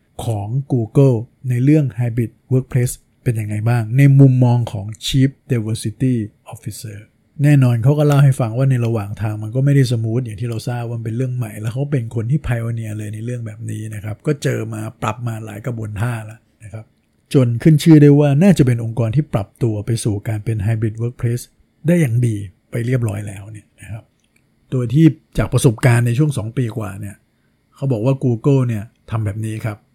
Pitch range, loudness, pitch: 110-130 Hz, -17 LUFS, 120 Hz